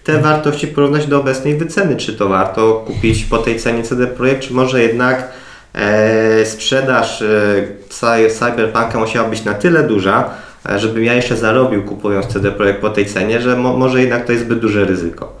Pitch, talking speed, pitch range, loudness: 115 Hz, 180 wpm, 105-130 Hz, -14 LUFS